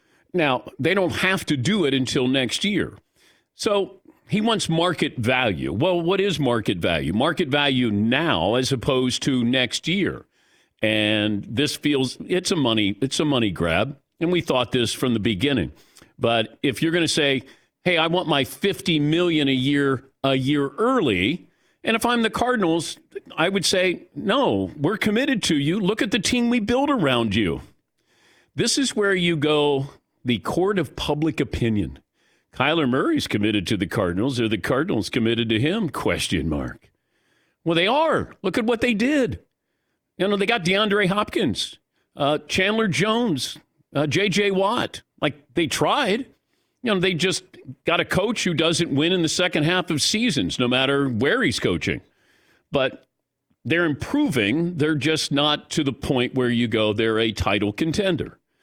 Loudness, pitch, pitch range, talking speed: -22 LUFS, 150 Hz, 130-190 Hz, 170 wpm